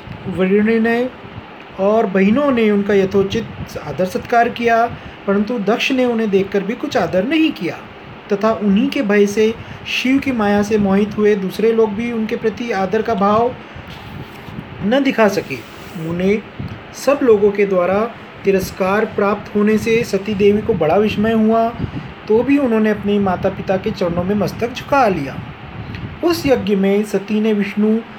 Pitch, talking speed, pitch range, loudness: 215 Hz, 160 wpm, 200-230 Hz, -16 LUFS